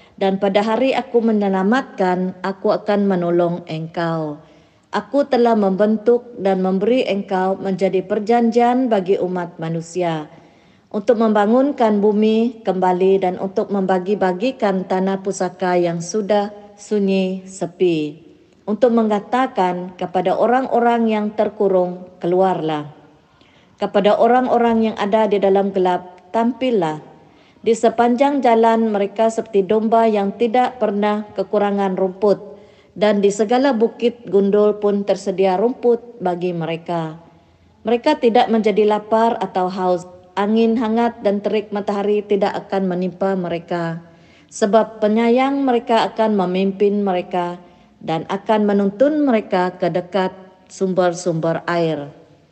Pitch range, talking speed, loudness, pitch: 185-225 Hz, 110 wpm, -18 LUFS, 200 Hz